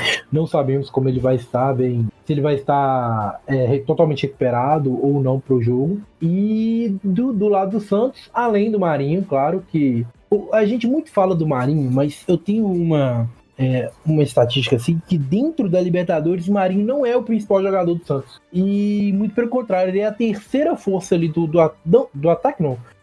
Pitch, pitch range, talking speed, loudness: 170 Hz, 135-205 Hz, 190 wpm, -19 LUFS